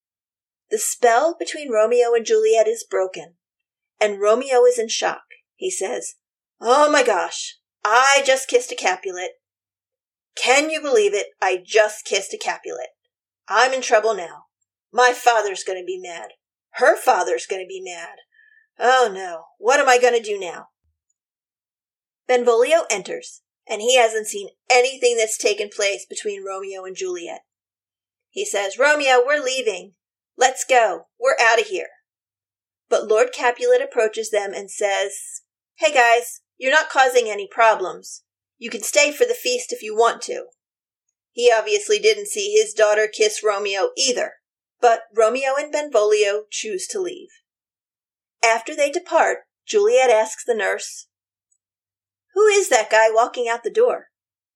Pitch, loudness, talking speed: 250 Hz, -19 LUFS, 150 wpm